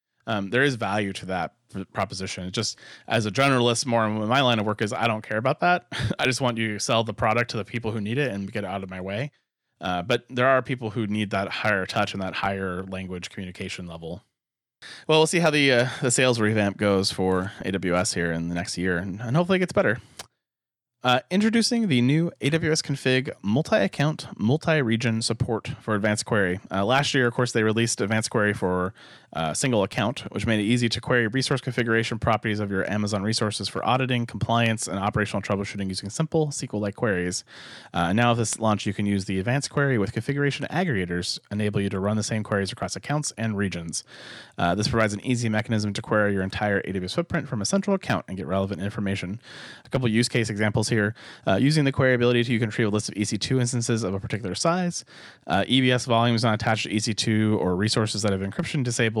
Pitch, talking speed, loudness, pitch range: 110 Hz, 215 wpm, -24 LUFS, 100-125 Hz